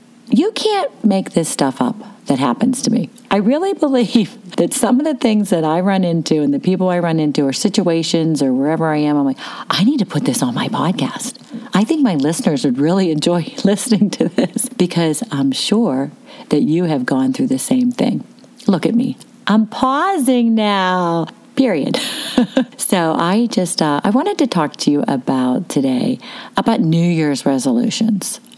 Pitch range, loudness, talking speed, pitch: 165-255 Hz, -16 LUFS, 185 wpm, 215 Hz